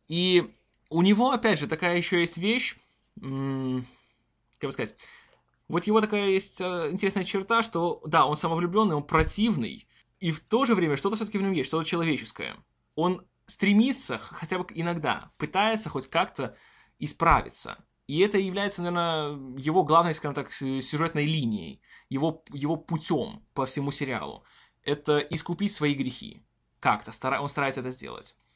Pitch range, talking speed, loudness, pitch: 145-195 Hz, 150 wpm, -27 LUFS, 165 Hz